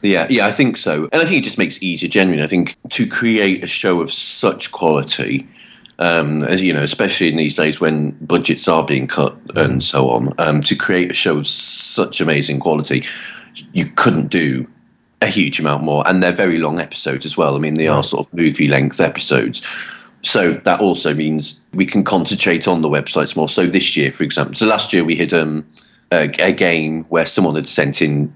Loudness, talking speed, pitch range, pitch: -15 LUFS, 215 wpm, 75-90 Hz, 80 Hz